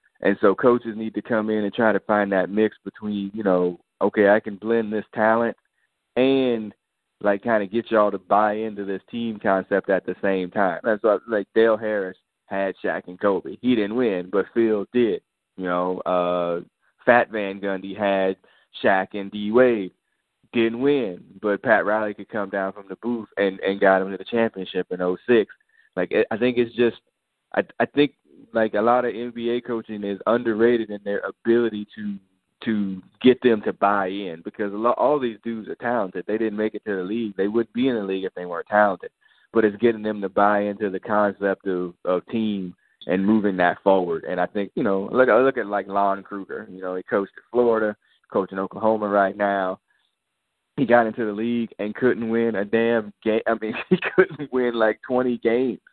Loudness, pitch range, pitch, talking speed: -23 LUFS, 95-115 Hz, 105 Hz, 205 wpm